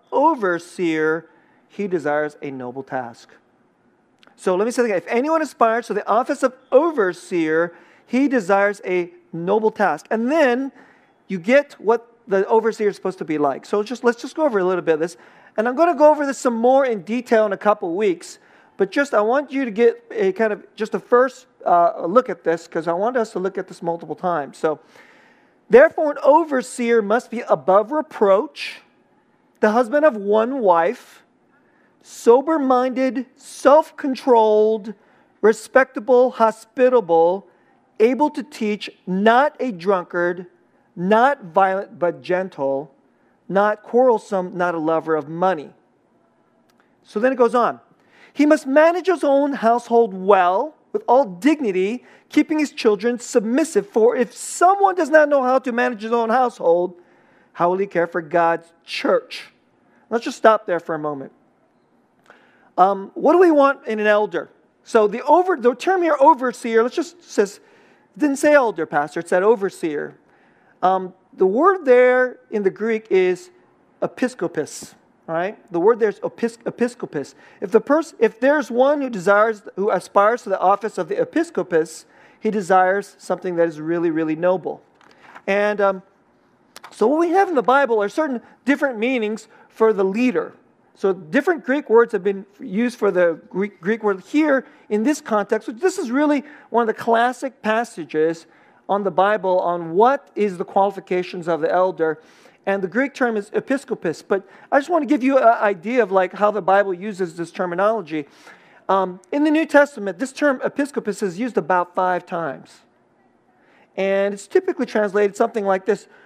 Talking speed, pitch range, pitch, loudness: 170 wpm, 190-270 Hz, 220 Hz, -19 LUFS